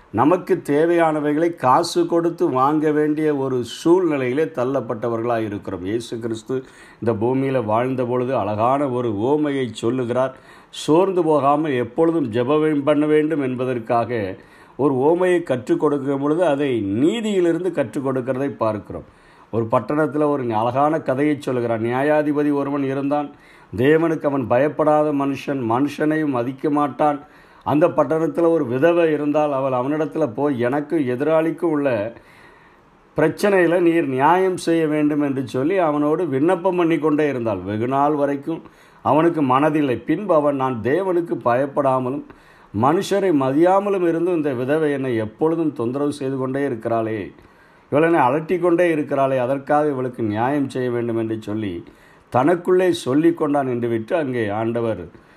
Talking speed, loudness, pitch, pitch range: 120 wpm, -20 LUFS, 145 Hz, 125-160 Hz